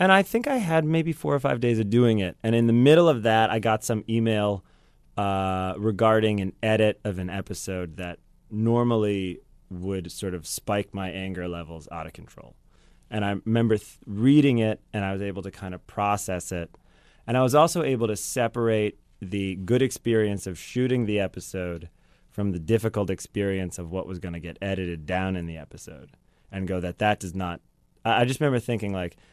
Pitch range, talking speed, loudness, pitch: 95-115 Hz, 200 wpm, -25 LUFS, 100 Hz